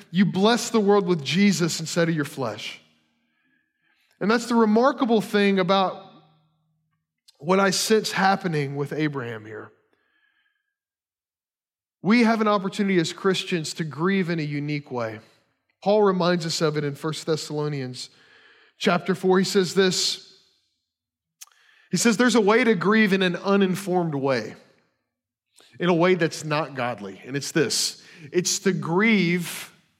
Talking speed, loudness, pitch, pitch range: 140 wpm, -22 LUFS, 180 Hz, 150-205 Hz